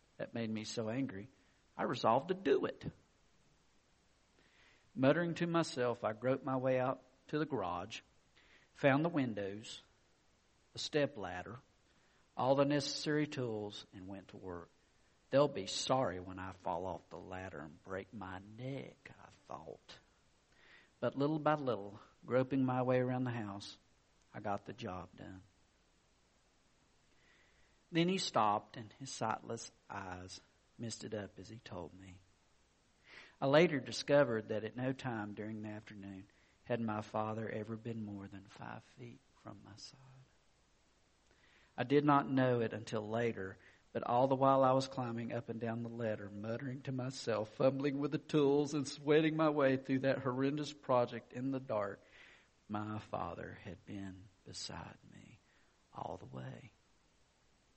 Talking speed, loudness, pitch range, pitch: 150 wpm, -37 LUFS, 100-135 Hz, 115 Hz